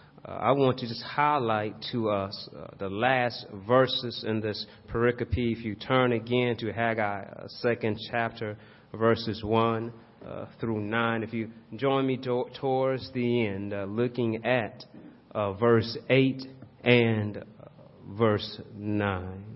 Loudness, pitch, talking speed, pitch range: -28 LUFS, 115 Hz, 140 wpm, 105-125 Hz